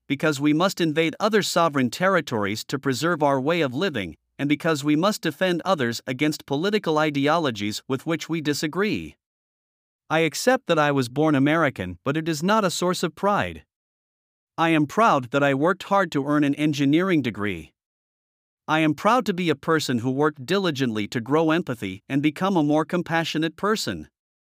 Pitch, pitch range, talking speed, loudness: 155 Hz, 135-170 Hz, 175 wpm, -23 LUFS